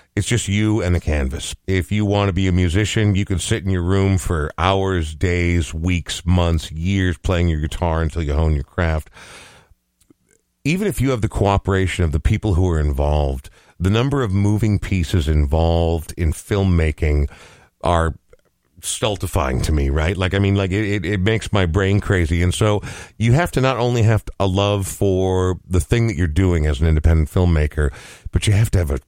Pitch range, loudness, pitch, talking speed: 80-100 Hz, -19 LUFS, 90 Hz, 195 wpm